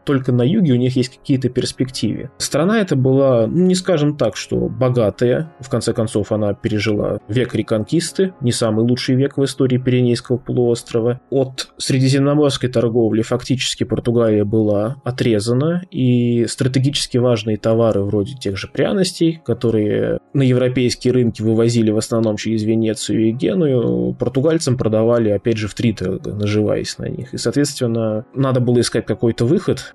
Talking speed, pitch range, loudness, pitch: 150 wpm, 110-135 Hz, -17 LUFS, 120 Hz